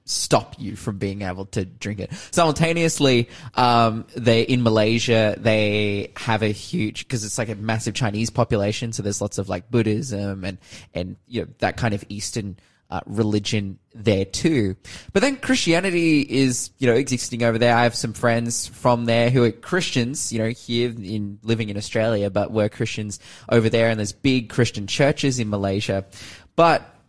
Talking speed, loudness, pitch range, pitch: 175 wpm, -21 LUFS, 105-120 Hz, 115 Hz